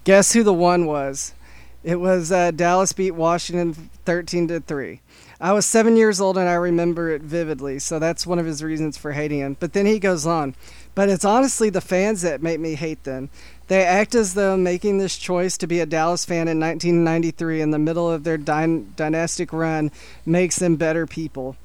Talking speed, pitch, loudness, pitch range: 205 wpm, 170 Hz, -20 LUFS, 160-185 Hz